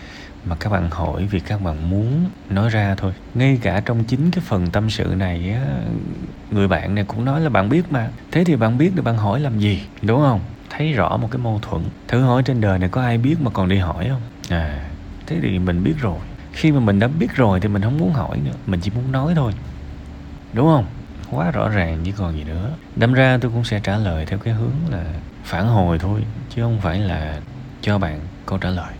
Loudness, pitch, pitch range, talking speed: -20 LUFS, 105 Hz, 95-130 Hz, 240 wpm